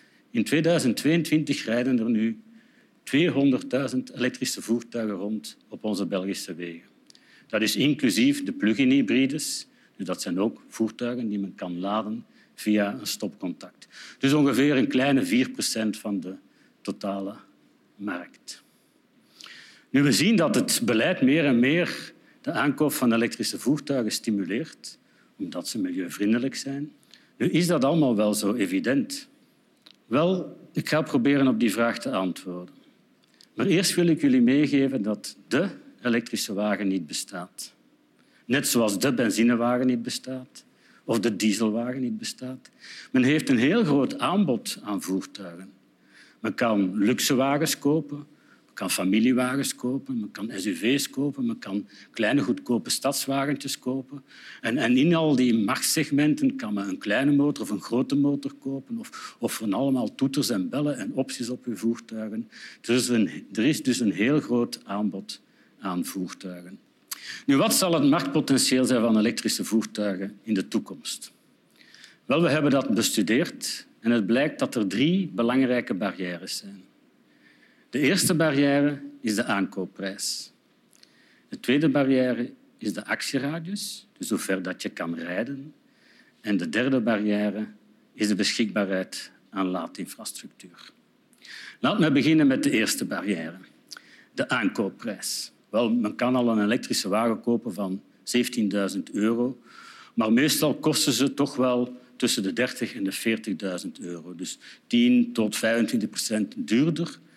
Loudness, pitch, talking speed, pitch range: -25 LUFS, 125 Hz, 145 wpm, 110-150 Hz